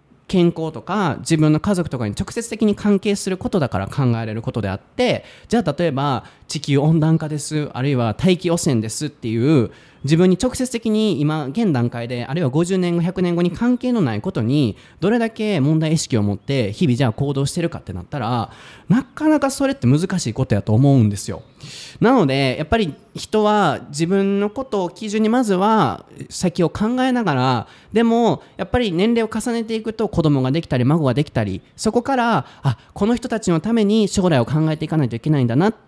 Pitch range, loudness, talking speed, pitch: 130-210 Hz, -19 LUFS, 385 characters per minute, 160 Hz